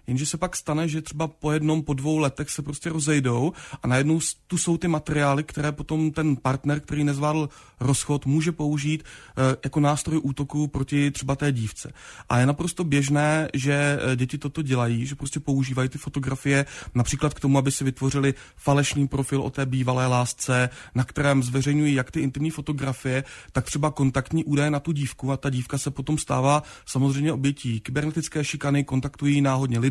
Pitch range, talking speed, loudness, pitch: 135-150 Hz, 175 wpm, -24 LUFS, 145 Hz